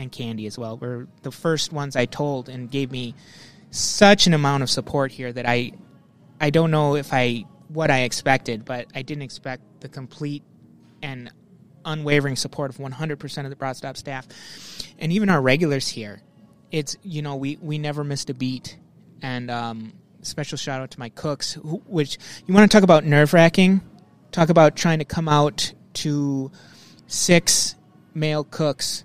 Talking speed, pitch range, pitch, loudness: 175 wpm, 130-155 Hz, 145 Hz, -21 LUFS